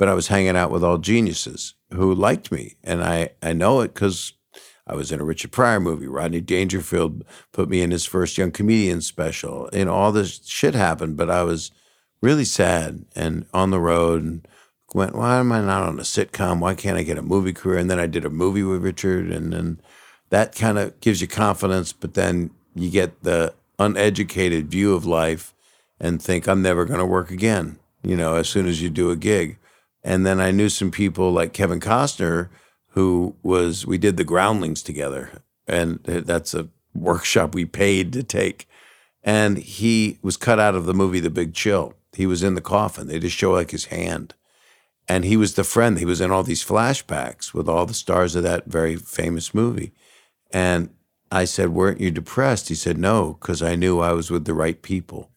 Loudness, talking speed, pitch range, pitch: -21 LUFS, 205 wpm, 85-100 Hz, 90 Hz